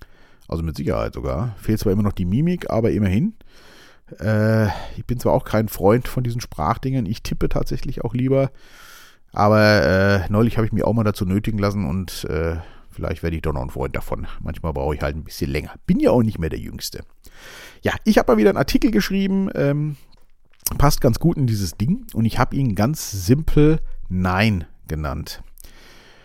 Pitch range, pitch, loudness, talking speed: 95-130 Hz, 110 Hz, -21 LUFS, 195 wpm